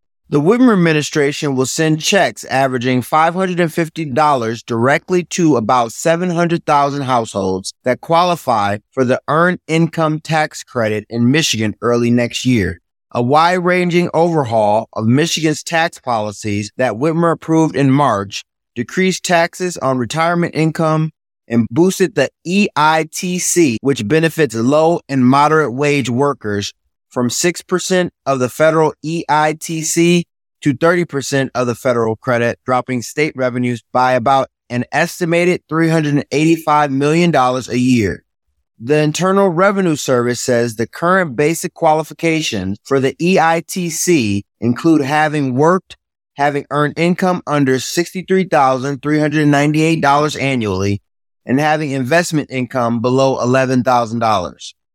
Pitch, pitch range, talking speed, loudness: 145 Hz, 125-165 Hz, 115 wpm, -15 LUFS